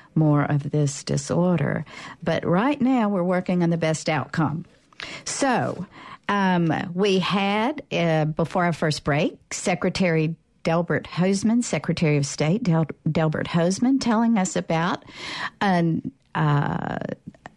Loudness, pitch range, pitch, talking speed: -23 LUFS, 155-190 Hz, 170 Hz, 125 wpm